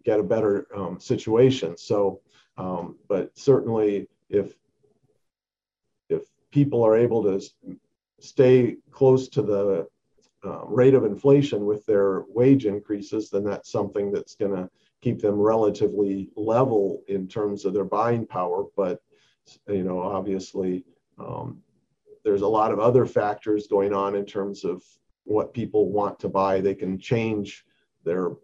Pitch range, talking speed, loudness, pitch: 100-130 Hz, 145 wpm, -24 LUFS, 105 Hz